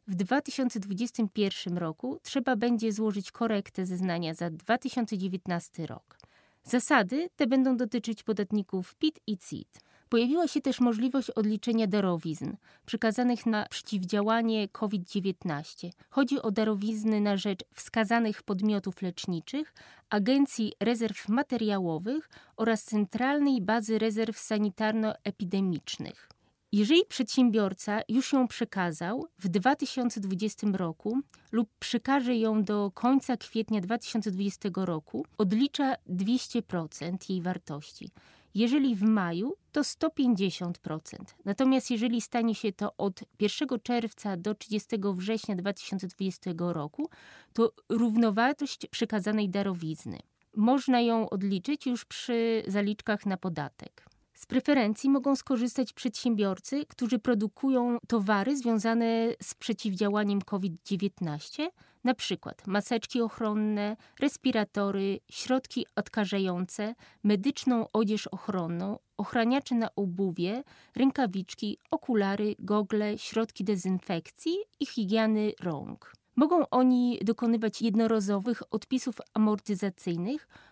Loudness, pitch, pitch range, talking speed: -30 LUFS, 220 Hz, 200-245 Hz, 100 wpm